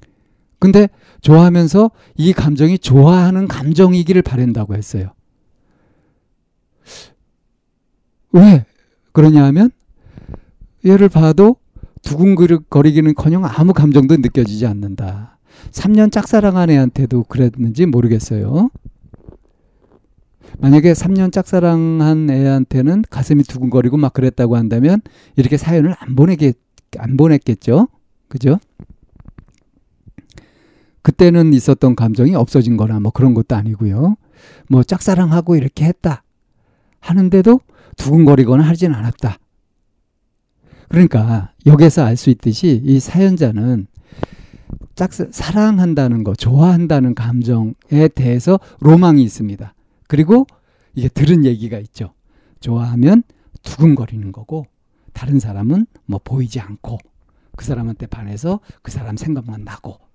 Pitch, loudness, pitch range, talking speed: 140 Hz, -12 LUFS, 115-170 Hz, 260 characters per minute